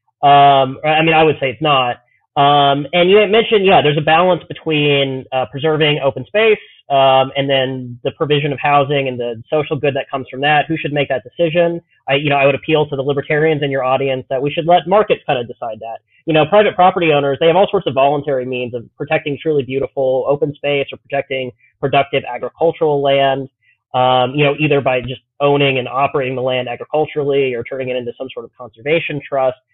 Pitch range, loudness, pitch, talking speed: 130-155 Hz, -15 LUFS, 140 Hz, 215 wpm